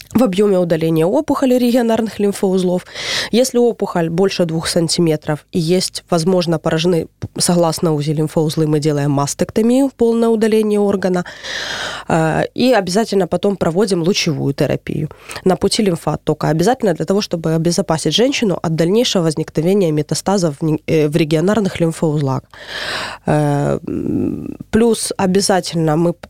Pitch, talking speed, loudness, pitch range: 175 Hz, 110 wpm, -16 LUFS, 160-205 Hz